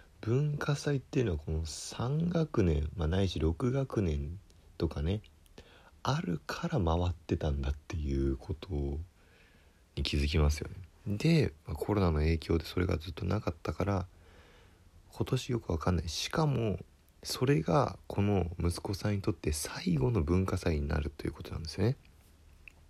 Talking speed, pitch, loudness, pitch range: 295 characters per minute, 85 Hz, -33 LUFS, 80-105 Hz